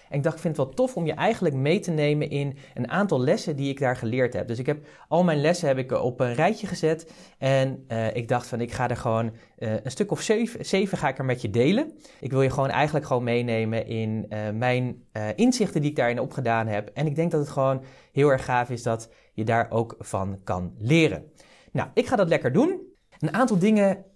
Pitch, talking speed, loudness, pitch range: 135 Hz, 245 wpm, -25 LUFS, 120-165 Hz